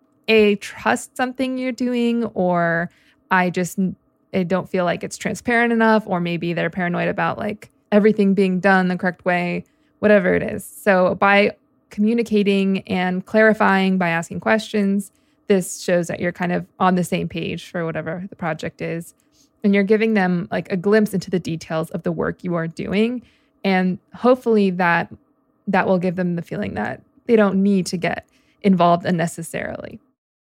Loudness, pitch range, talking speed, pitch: -20 LUFS, 180-215 Hz, 170 wpm, 195 Hz